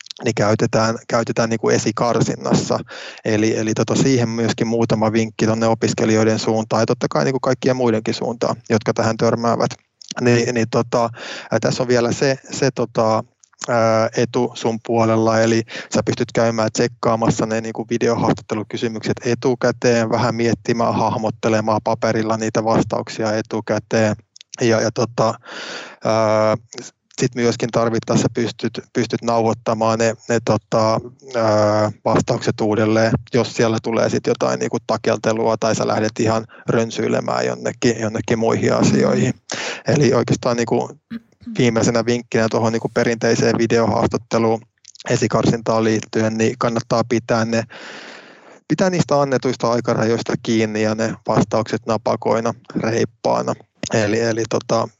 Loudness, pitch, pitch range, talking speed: -19 LUFS, 115 Hz, 110-120 Hz, 125 wpm